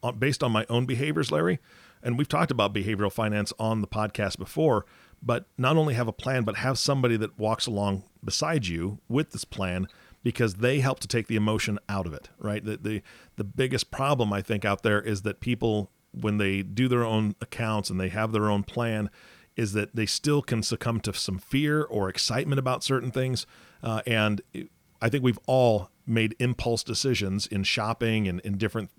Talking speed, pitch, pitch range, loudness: 200 wpm, 110 Hz, 105-125 Hz, -27 LUFS